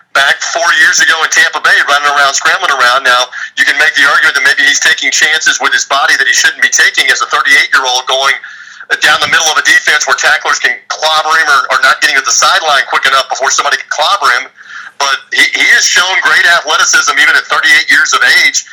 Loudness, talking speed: -7 LUFS, 235 wpm